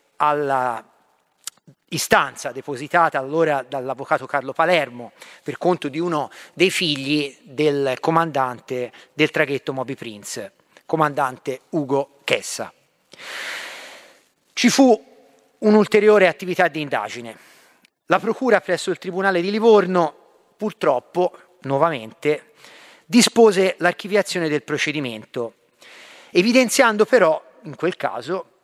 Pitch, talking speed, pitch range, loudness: 155 Hz, 95 wpm, 135-185 Hz, -20 LUFS